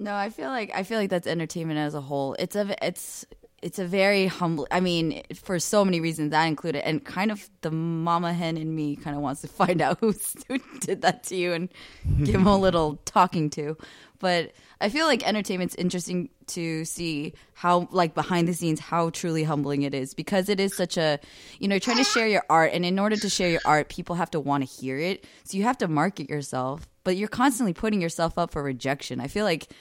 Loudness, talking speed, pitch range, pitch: -26 LUFS, 230 wpm, 155-195 Hz, 170 Hz